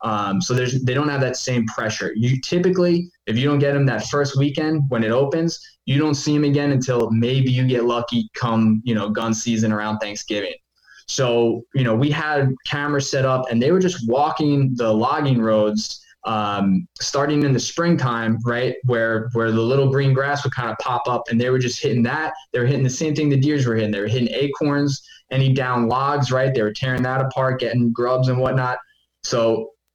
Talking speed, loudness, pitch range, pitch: 210 wpm, -20 LUFS, 115-145 Hz, 130 Hz